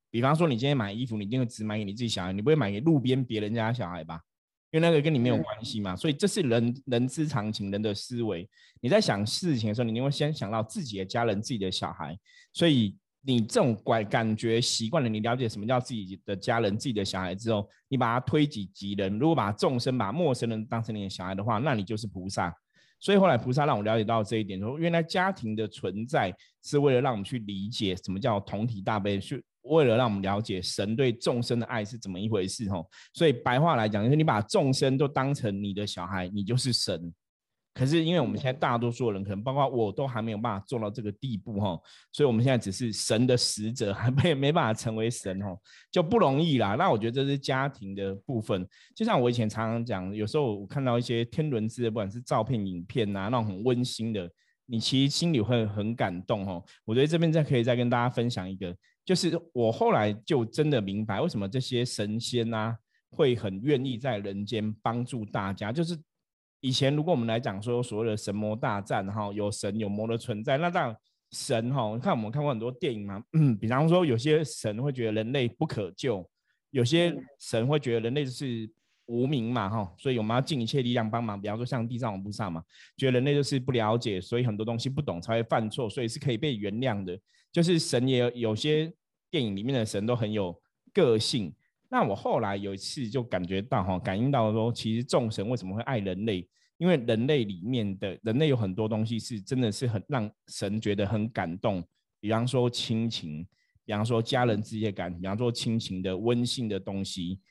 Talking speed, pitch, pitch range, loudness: 335 characters per minute, 115 Hz, 105-130 Hz, -28 LUFS